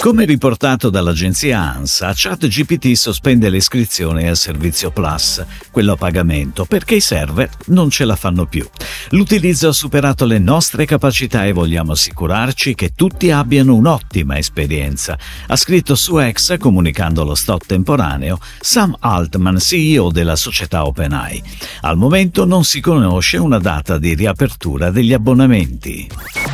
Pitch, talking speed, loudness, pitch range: 105 Hz, 135 wpm, -13 LUFS, 85-140 Hz